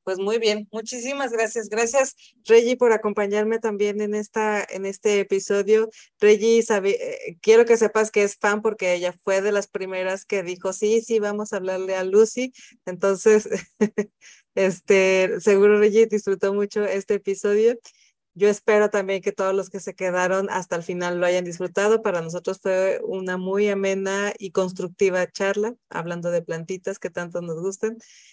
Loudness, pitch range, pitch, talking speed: -22 LUFS, 190-220 Hz, 205 Hz, 165 wpm